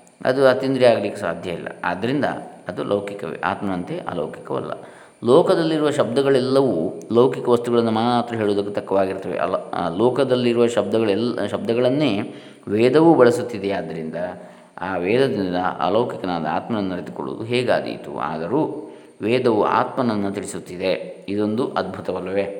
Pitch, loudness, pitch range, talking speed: 110 Hz, -21 LUFS, 100-125 Hz, 95 wpm